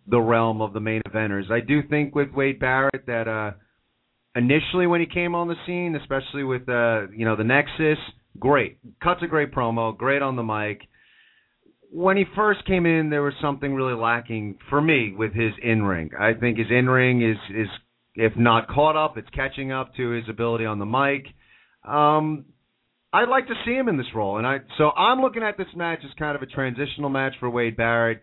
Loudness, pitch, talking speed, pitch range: -23 LUFS, 130 Hz, 210 wpm, 115-150 Hz